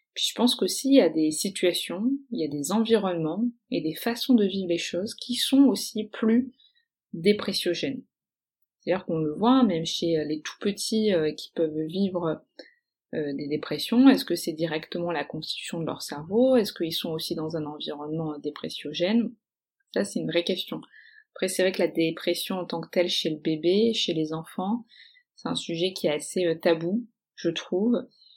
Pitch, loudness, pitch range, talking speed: 185 Hz, -26 LUFS, 165-235 Hz, 185 wpm